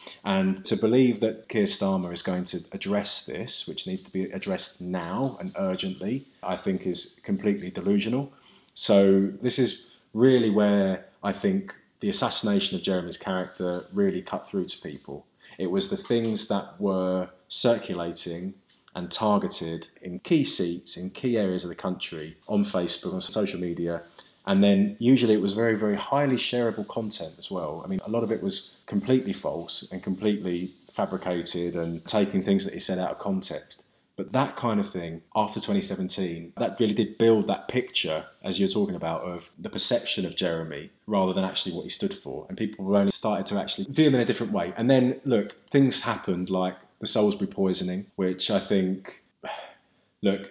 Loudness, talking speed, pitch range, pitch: -26 LUFS, 180 wpm, 90-125 Hz, 100 Hz